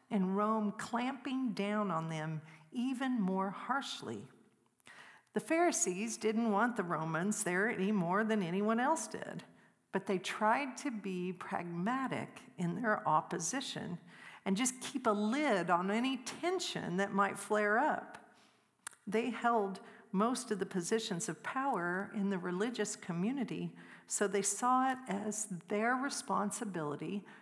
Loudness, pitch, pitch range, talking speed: -35 LUFS, 210 Hz, 190-235 Hz, 135 wpm